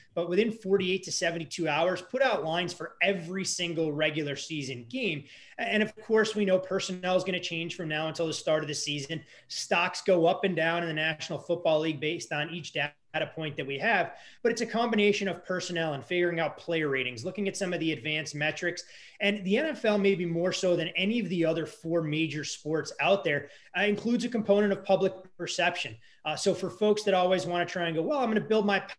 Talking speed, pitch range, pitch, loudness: 225 wpm, 155-195 Hz, 175 Hz, -29 LUFS